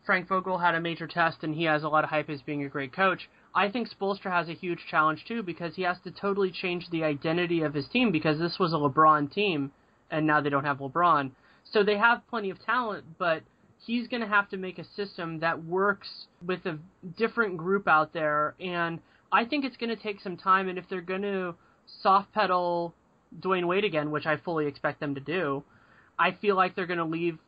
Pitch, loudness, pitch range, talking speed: 175 Hz, -28 LUFS, 155-195 Hz, 230 wpm